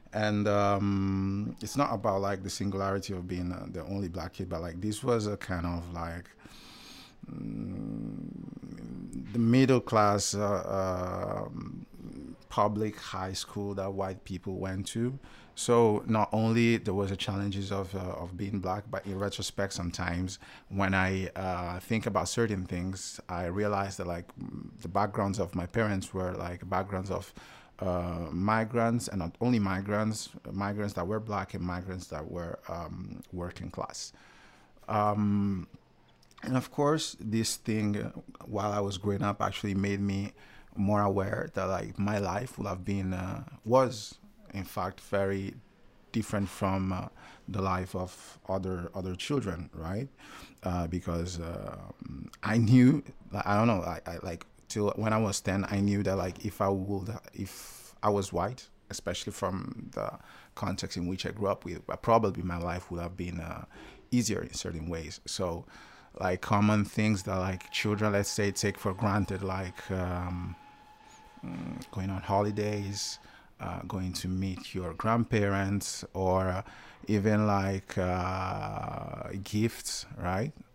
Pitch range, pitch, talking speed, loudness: 90-105 Hz, 100 Hz, 150 wpm, -32 LUFS